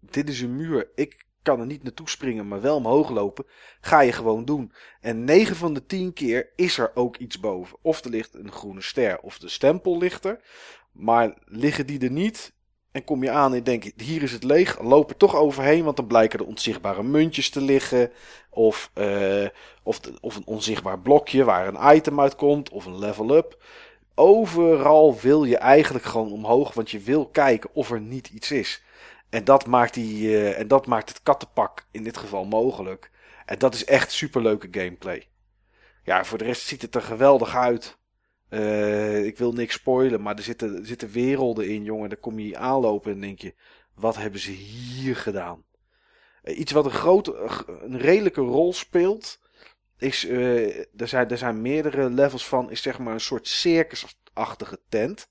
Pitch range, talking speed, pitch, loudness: 110-145 Hz, 195 wpm, 125 Hz, -22 LUFS